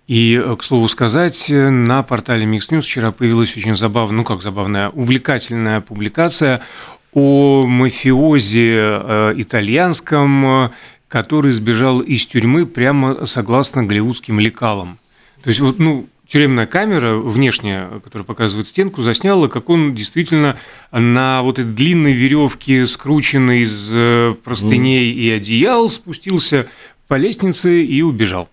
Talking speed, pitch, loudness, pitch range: 120 wpm, 125 Hz, -14 LUFS, 115-145 Hz